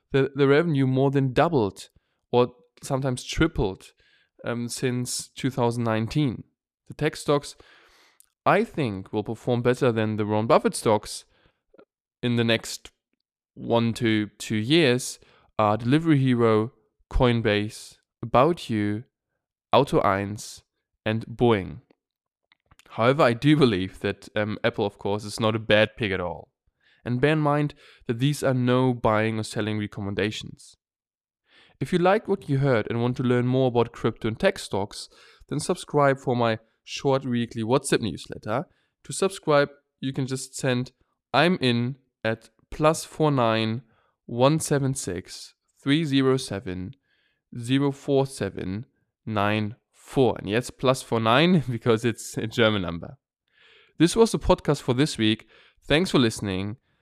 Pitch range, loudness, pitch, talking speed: 110-140 Hz, -24 LUFS, 120 Hz, 145 wpm